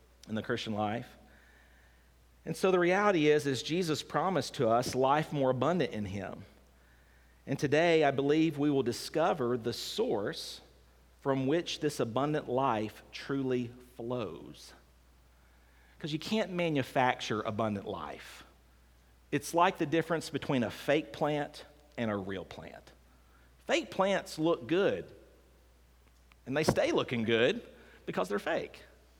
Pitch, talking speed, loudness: 120 Hz, 135 wpm, -32 LUFS